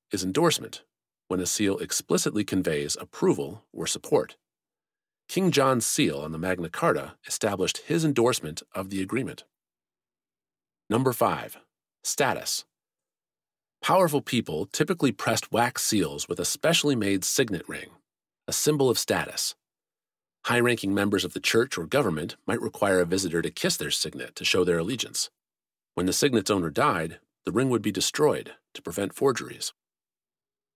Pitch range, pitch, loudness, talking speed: 75-120 Hz, 95 Hz, -26 LUFS, 145 wpm